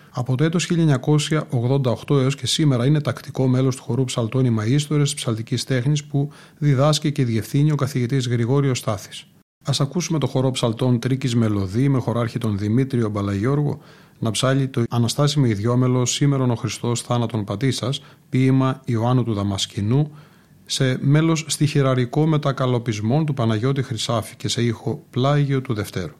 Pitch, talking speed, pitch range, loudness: 130 Hz, 145 wpm, 120-145 Hz, -21 LUFS